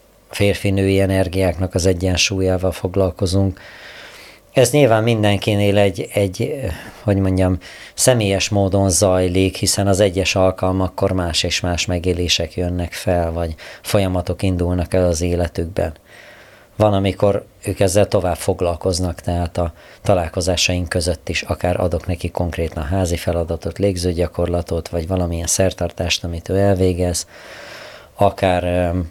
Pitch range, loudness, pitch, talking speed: 90-100 Hz, -18 LUFS, 95 Hz, 120 wpm